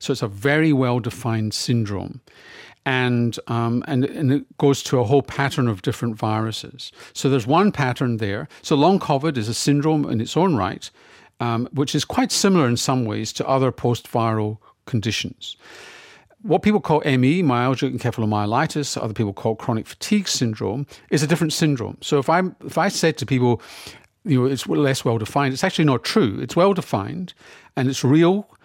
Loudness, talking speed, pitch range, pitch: -21 LUFS, 185 wpm, 115-150 Hz, 135 Hz